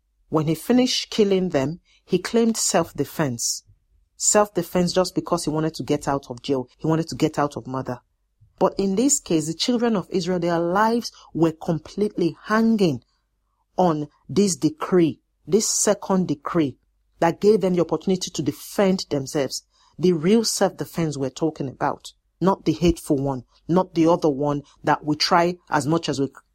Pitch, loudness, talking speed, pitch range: 165 Hz, -22 LUFS, 165 wpm, 145-185 Hz